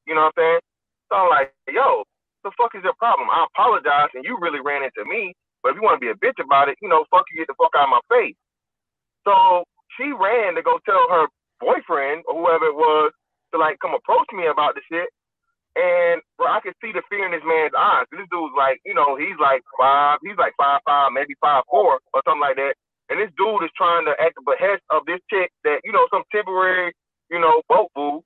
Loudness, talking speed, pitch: -19 LUFS, 245 wpm, 185 Hz